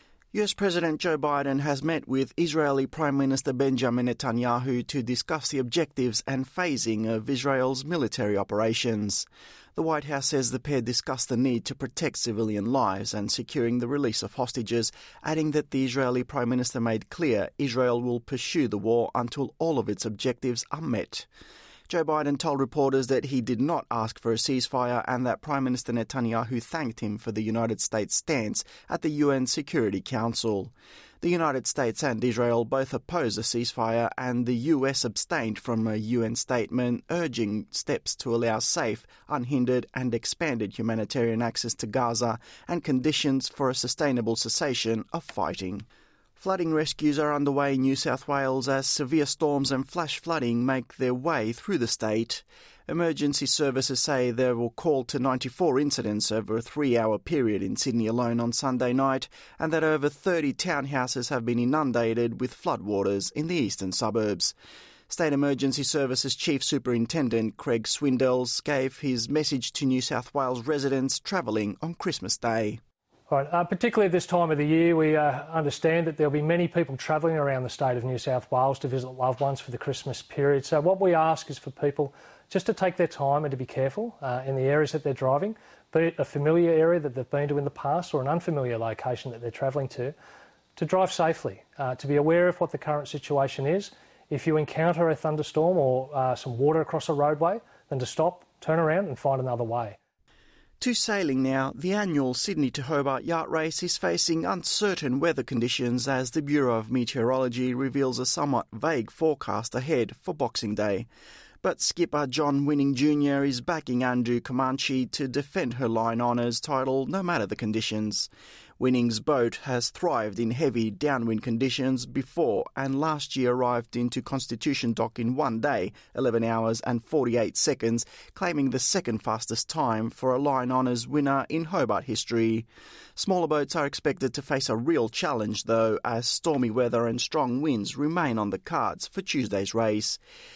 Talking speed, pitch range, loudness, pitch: 180 wpm, 120-150 Hz, -27 LUFS, 130 Hz